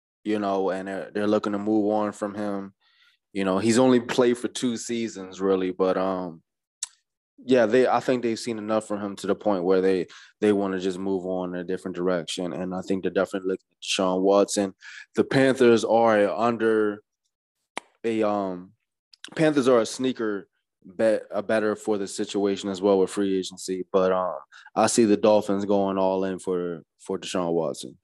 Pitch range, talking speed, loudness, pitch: 95-110 Hz, 195 wpm, -24 LUFS, 100 Hz